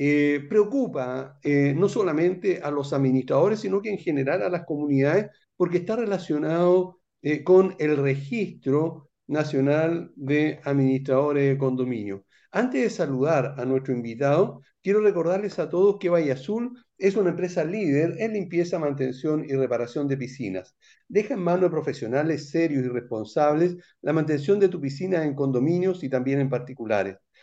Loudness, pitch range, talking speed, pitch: -24 LUFS, 135-180 Hz, 155 wpm, 150 Hz